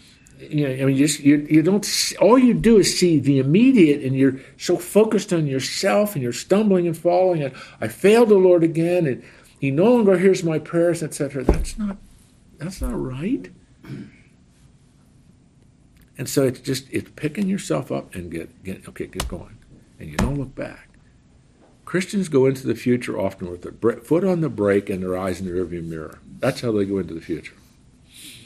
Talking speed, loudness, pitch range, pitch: 195 wpm, -20 LUFS, 125-185 Hz, 145 Hz